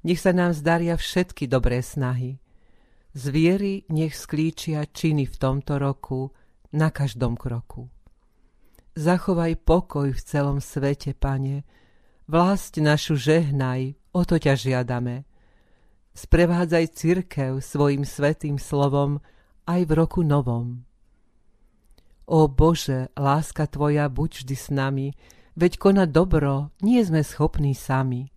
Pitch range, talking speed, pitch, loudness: 135-165 Hz, 115 wpm, 145 Hz, -23 LUFS